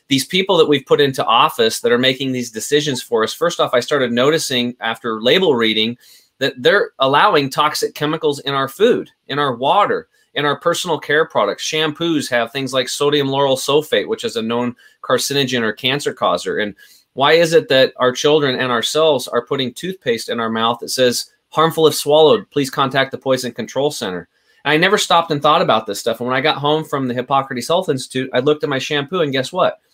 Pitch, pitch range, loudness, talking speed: 140 Hz, 125-150 Hz, -16 LUFS, 210 wpm